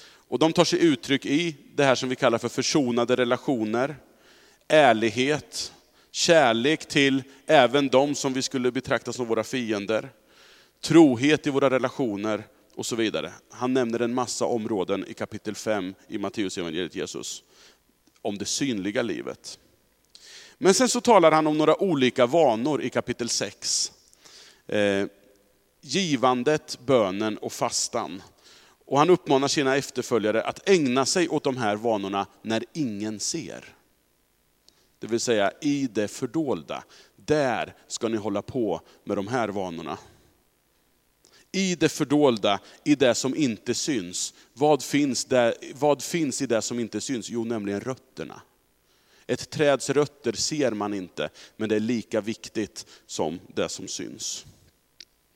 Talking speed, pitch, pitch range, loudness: 140 wpm, 125 Hz, 110-145 Hz, -25 LUFS